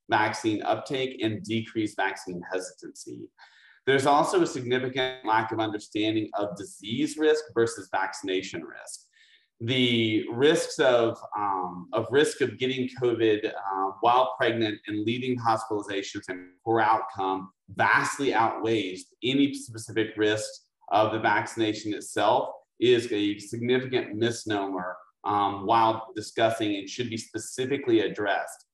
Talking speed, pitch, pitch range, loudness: 120 wpm, 110 Hz, 105-130 Hz, -27 LUFS